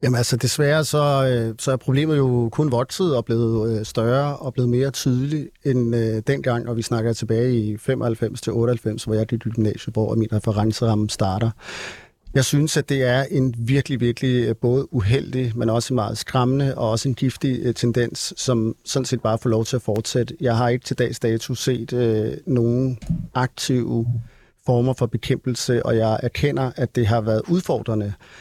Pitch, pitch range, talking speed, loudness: 120 Hz, 115-130 Hz, 180 wpm, -21 LUFS